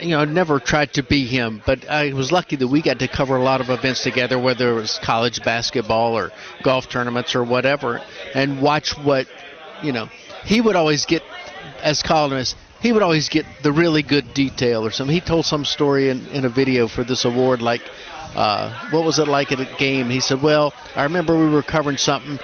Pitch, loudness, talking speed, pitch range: 140 Hz, -19 LUFS, 220 wpm, 130-150 Hz